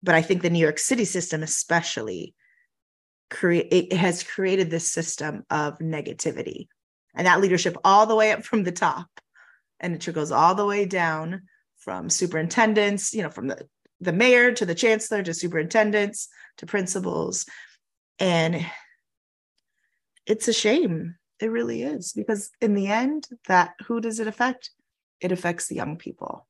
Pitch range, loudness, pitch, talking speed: 170-215 Hz, -23 LUFS, 190 Hz, 160 wpm